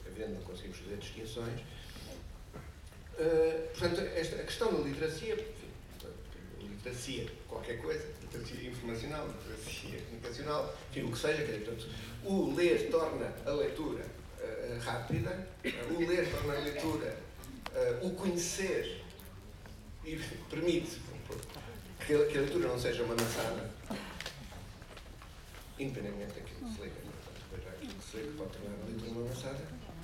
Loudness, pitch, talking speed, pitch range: -37 LUFS, 120 Hz, 130 wpm, 105-160 Hz